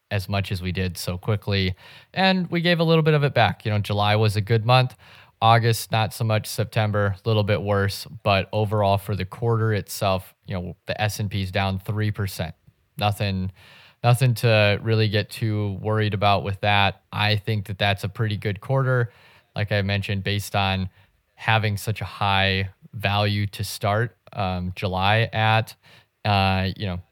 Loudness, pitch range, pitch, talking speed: -23 LUFS, 100-115 Hz, 105 Hz, 185 wpm